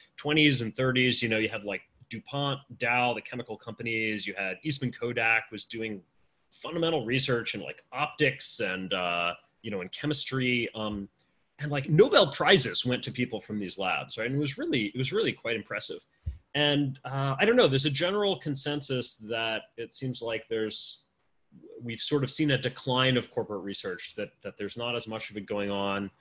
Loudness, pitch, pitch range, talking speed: -28 LUFS, 120 Hz, 105-135 Hz, 190 wpm